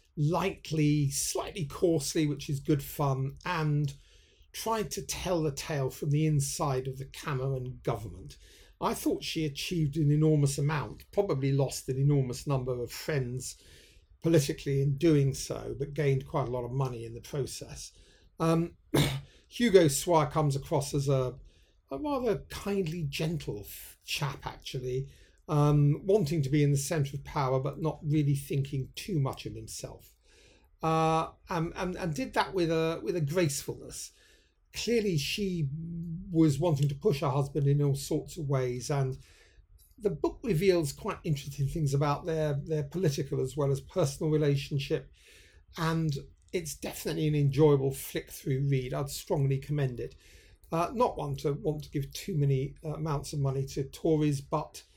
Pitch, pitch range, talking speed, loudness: 145 Hz, 135-160 Hz, 160 wpm, -30 LUFS